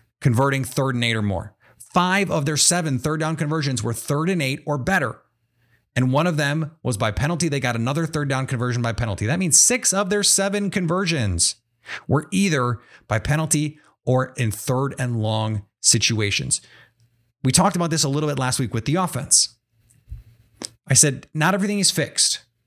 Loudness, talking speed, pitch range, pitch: -20 LUFS, 185 wpm, 115-155 Hz, 135 Hz